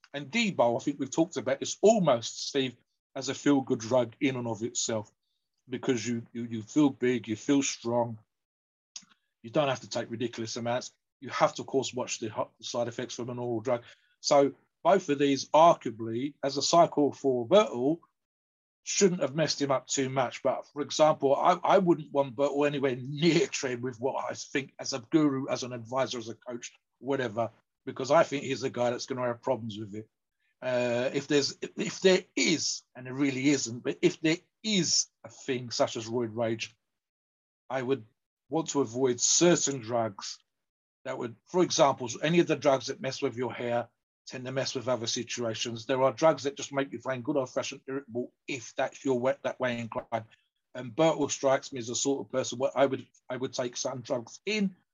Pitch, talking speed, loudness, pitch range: 130 Hz, 205 wpm, -29 LUFS, 120-140 Hz